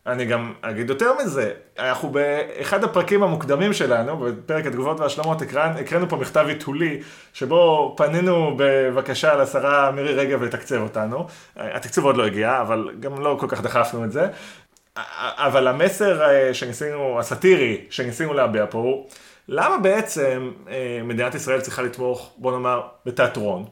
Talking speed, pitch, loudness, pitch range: 135 wpm, 140 Hz, -21 LUFS, 125-155 Hz